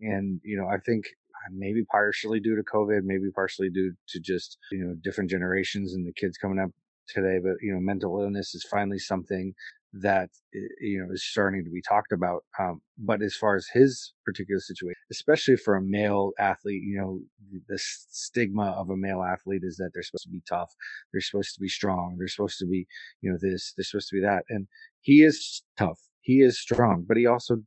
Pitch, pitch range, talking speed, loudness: 100 Hz, 95-105 Hz, 210 wpm, -27 LUFS